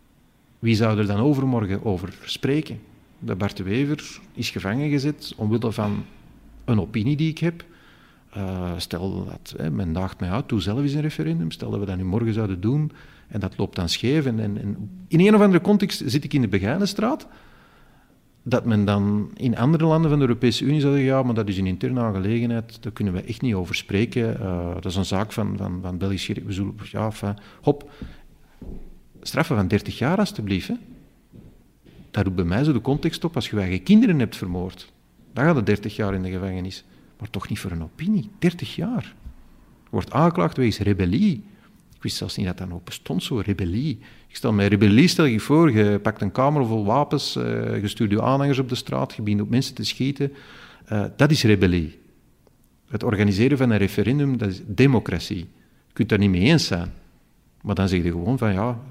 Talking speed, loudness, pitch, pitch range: 205 wpm, -22 LUFS, 110 Hz, 100-135 Hz